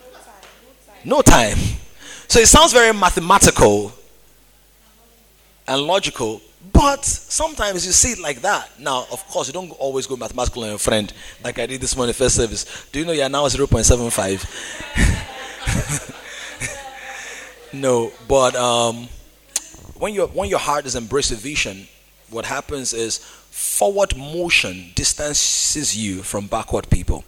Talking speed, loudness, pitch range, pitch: 150 wpm, -18 LUFS, 115-150 Hz, 130 Hz